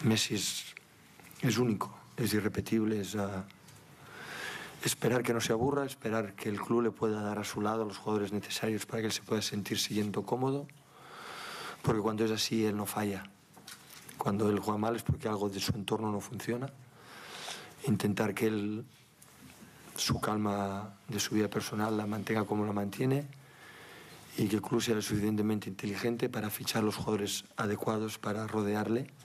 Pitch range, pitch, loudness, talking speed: 105-115 Hz, 110 Hz, -33 LUFS, 170 wpm